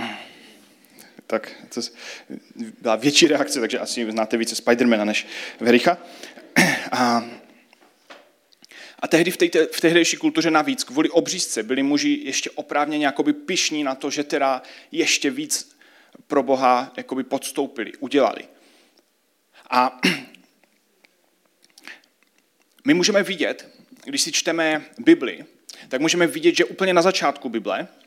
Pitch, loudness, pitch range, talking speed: 160 Hz, -21 LUFS, 135-200 Hz, 120 wpm